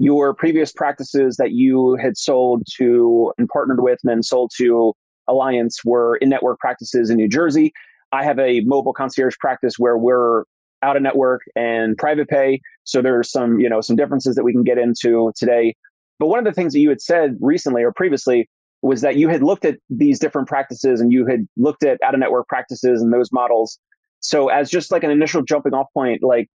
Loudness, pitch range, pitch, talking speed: -17 LUFS, 120-145 Hz, 130 Hz, 200 wpm